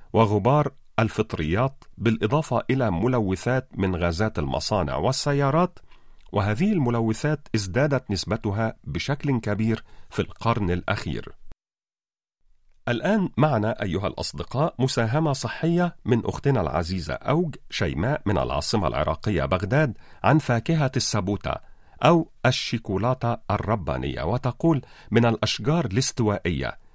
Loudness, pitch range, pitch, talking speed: -24 LUFS, 100-135 Hz, 115 Hz, 95 wpm